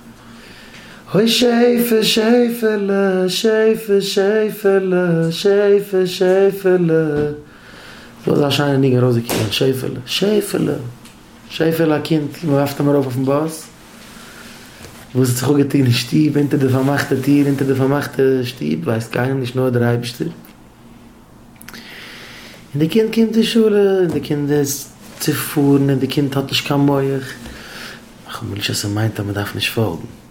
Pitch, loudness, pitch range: 145 Hz, -16 LUFS, 130-190 Hz